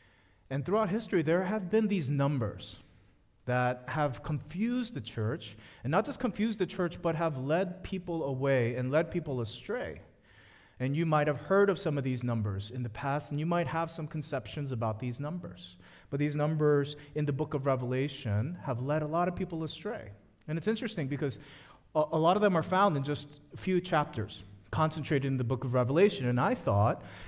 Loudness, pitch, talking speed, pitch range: -32 LUFS, 145 Hz, 195 wpm, 125-170 Hz